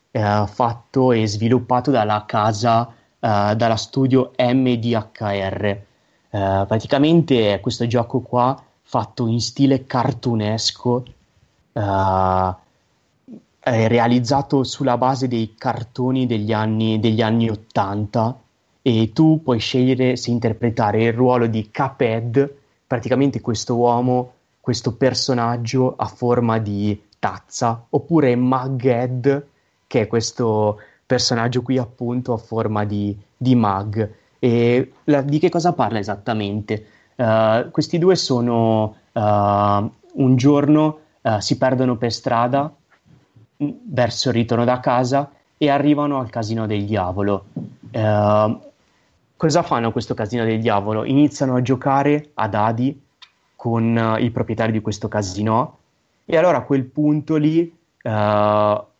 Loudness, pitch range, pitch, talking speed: -19 LUFS, 110-130 Hz, 120 Hz, 120 wpm